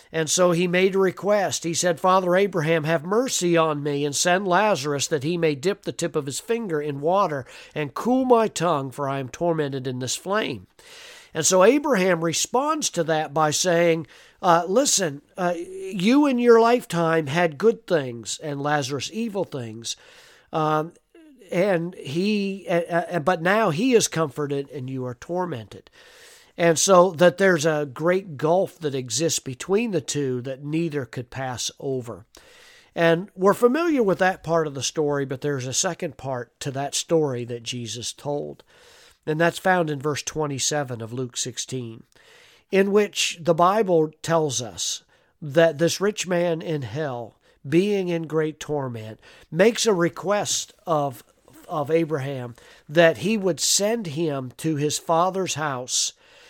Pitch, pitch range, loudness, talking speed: 165 Hz, 145-190 Hz, -23 LUFS, 160 wpm